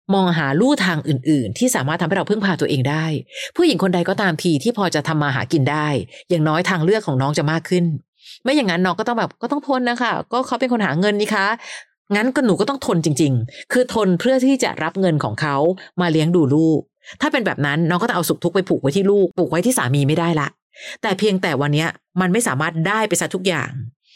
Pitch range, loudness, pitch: 155-220 Hz, -19 LUFS, 180 Hz